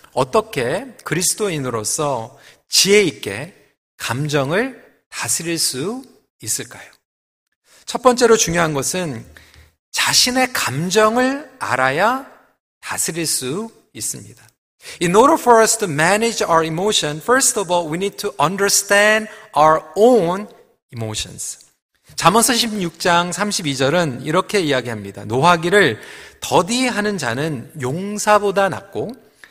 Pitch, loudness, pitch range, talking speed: 180 Hz, -17 LUFS, 145-215 Hz, 315 characters per minute